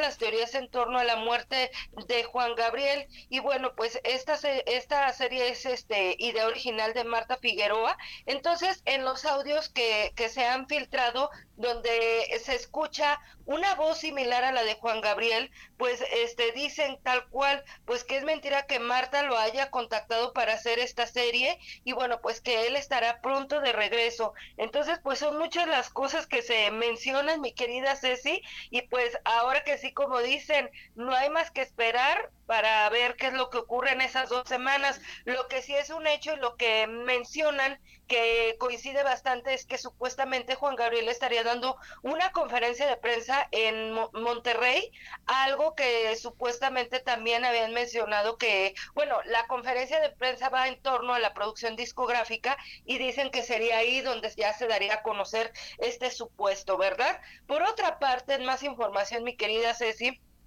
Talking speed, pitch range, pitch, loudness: 170 wpm, 230-275 Hz, 250 Hz, -28 LUFS